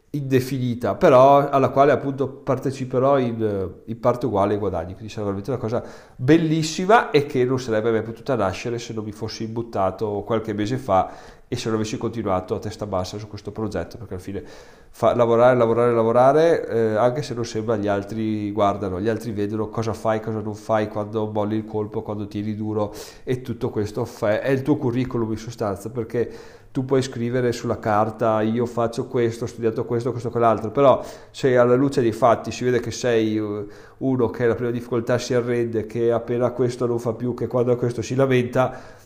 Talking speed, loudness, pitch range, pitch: 195 wpm, -22 LUFS, 110-125 Hz, 115 Hz